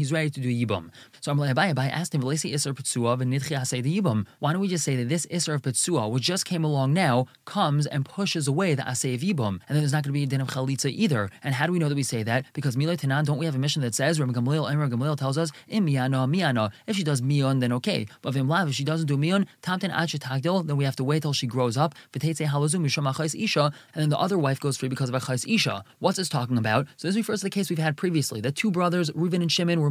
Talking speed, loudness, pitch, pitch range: 245 wpm, -25 LUFS, 145 Hz, 130-165 Hz